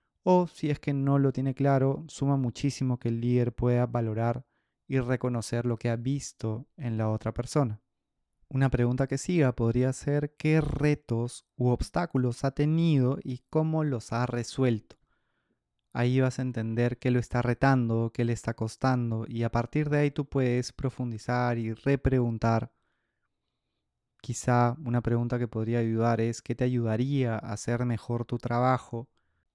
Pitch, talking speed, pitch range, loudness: 125 Hz, 160 wpm, 115-135 Hz, -28 LUFS